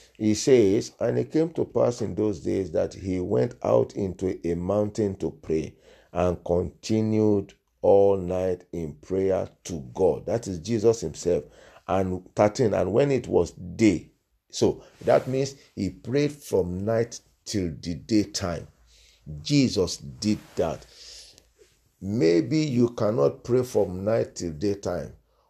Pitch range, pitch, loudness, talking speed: 85-110 Hz, 100 Hz, -25 LUFS, 140 wpm